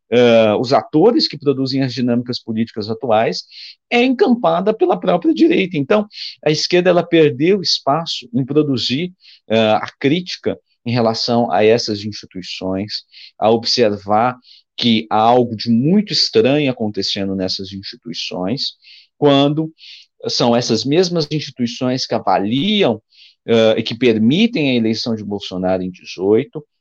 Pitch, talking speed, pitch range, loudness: 125 Hz, 130 wpm, 110-155 Hz, -16 LUFS